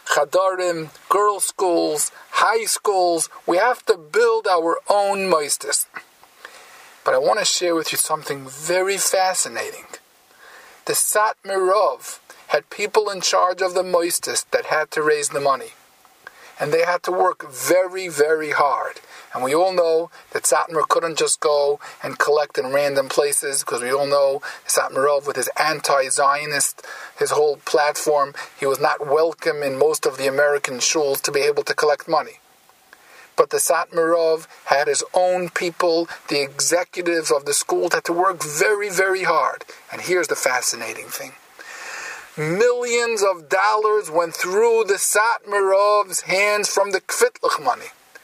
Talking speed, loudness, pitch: 150 wpm, -19 LUFS, 190 Hz